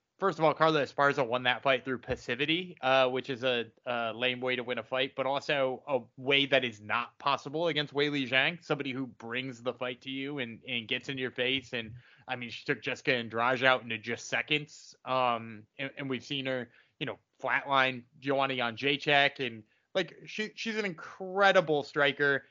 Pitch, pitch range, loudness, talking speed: 130 Hz, 125-145 Hz, -30 LUFS, 205 wpm